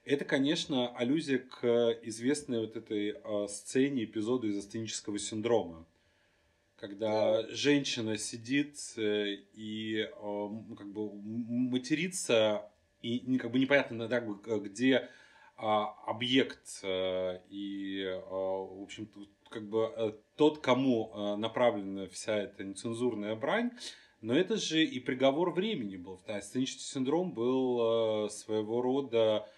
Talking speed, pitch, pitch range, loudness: 100 wpm, 110 Hz, 105-125 Hz, -33 LUFS